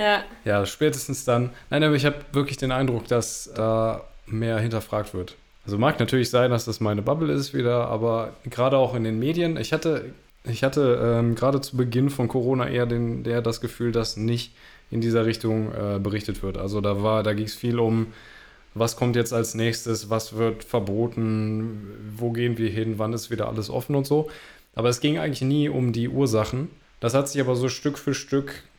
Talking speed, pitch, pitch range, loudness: 200 wpm, 115 Hz, 110-130 Hz, -24 LUFS